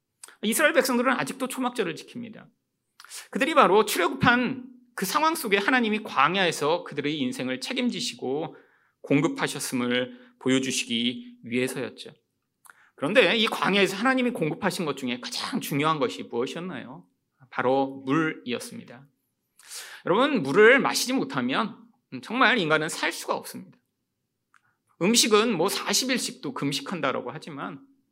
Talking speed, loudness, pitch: 315 characters per minute, -24 LUFS, 225 Hz